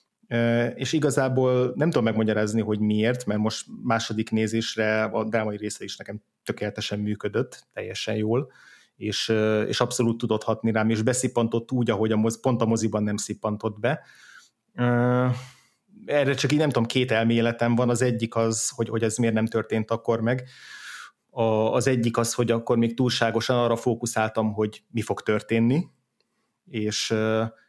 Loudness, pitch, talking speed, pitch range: -25 LUFS, 115 Hz, 155 wpm, 110-125 Hz